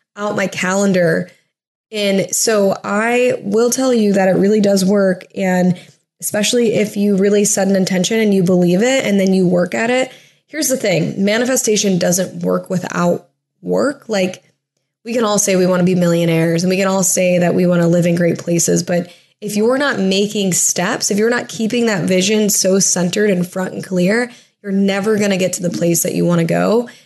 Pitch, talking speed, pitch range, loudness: 195 Hz, 210 wpm, 180-210 Hz, -15 LUFS